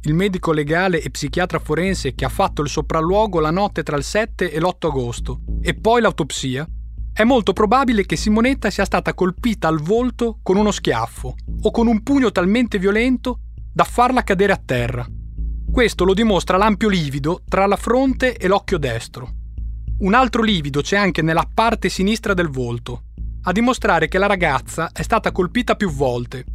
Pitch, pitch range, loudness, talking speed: 185 Hz, 155-215 Hz, -18 LUFS, 175 wpm